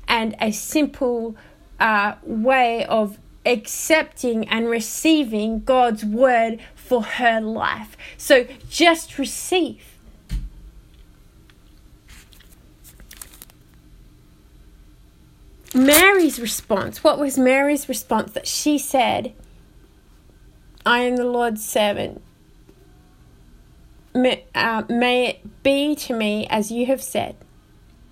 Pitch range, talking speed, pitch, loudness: 215-270 Hz, 90 wpm, 240 Hz, -19 LUFS